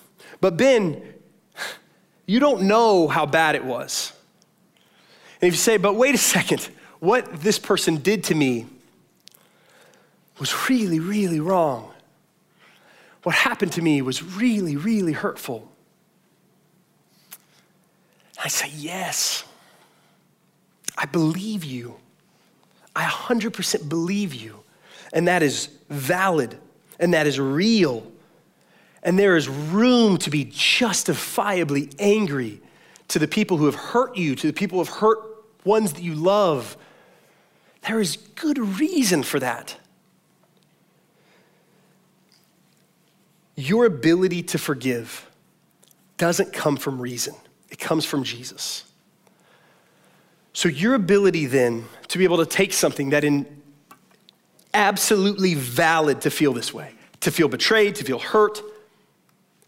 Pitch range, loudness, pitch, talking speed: 155-205 Hz, -21 LUFS, 180 Hz, 120 wpm